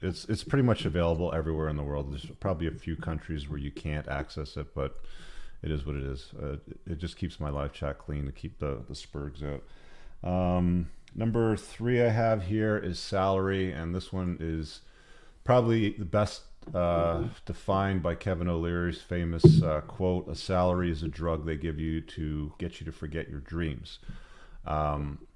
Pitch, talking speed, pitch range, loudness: 85 Hz, 185 wpm, 75-95 Hz, -30 LUFS